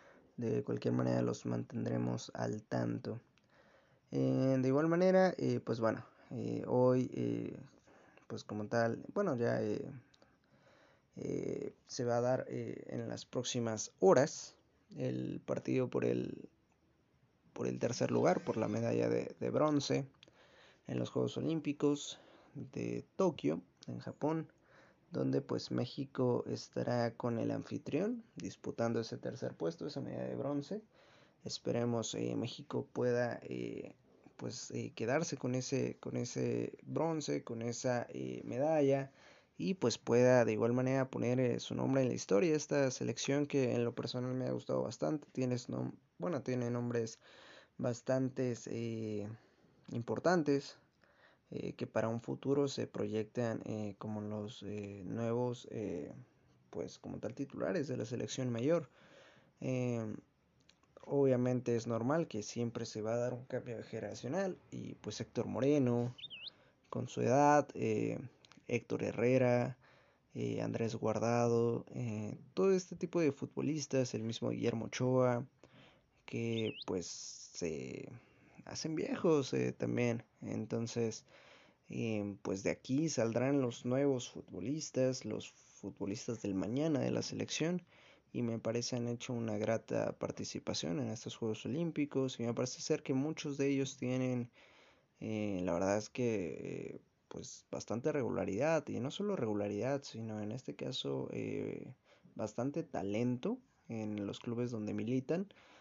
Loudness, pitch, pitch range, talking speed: -37 LUFS, 120 Hz, 105-135 Hz, 140 wpm